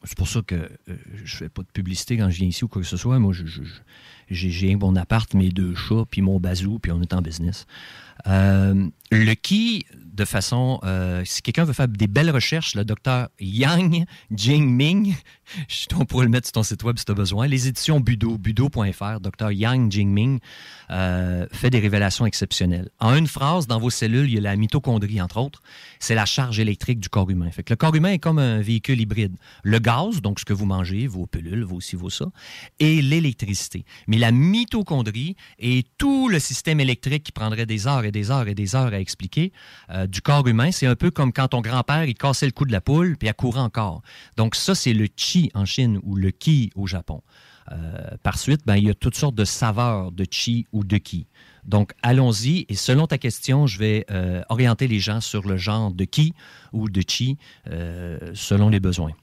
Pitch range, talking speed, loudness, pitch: 95-130 Hz, 220 wpm, -21 LUFS, 110 Hz